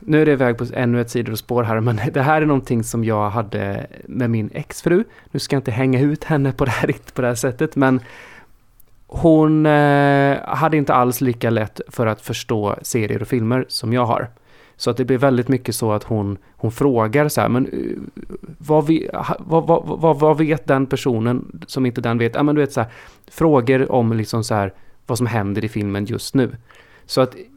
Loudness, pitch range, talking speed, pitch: -19 LUFS, 115-145 Hz, 215 wpm, 125 Hz